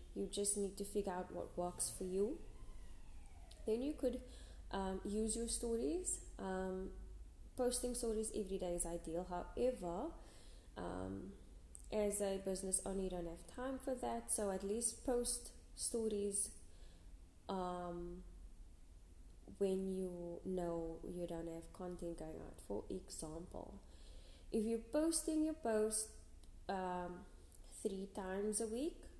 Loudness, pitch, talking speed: -43 LUFS, 185 Hz, 130 wpm